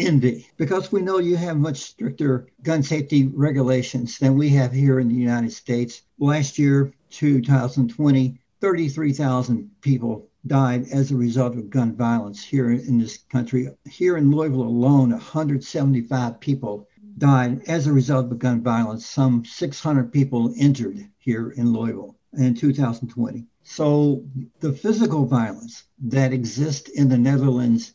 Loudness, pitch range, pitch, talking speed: -21 LUFS, 120-145 Hz, 135 Hz, 140 wpm